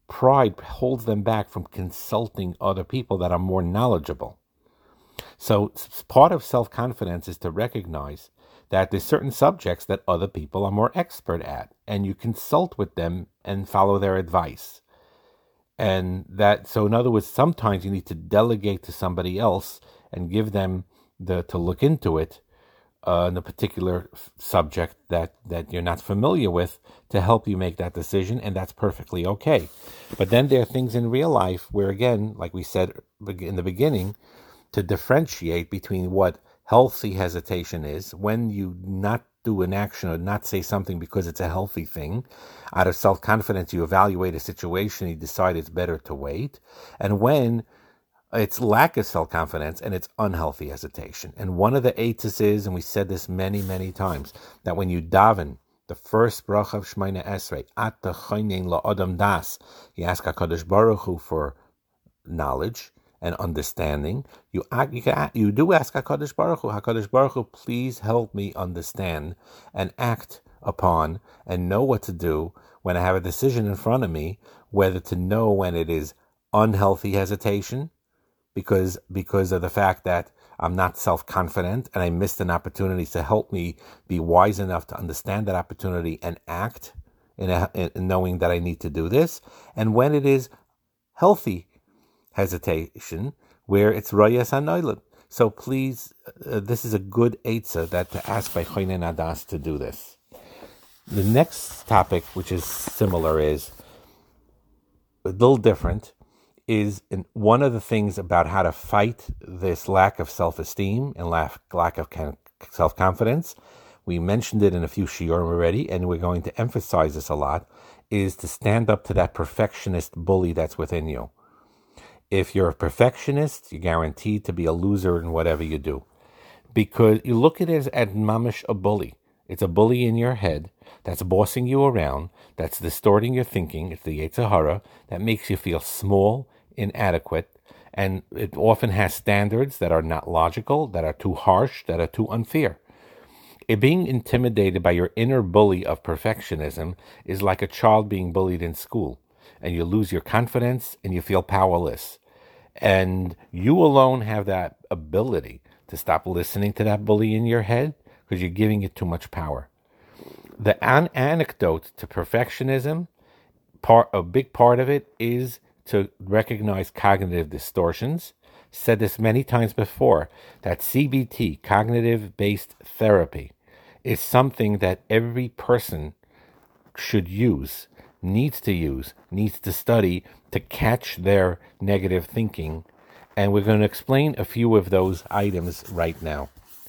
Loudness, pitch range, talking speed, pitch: -23 LUFS, 90-110 Hz, 165 wpm, 100 Hz